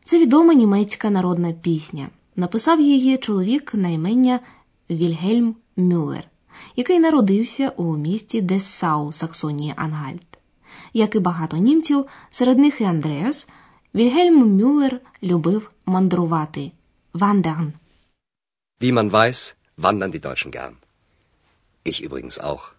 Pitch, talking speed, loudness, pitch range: 195 Hz, 90 wpm, -19 LUFS, 165-250 Hz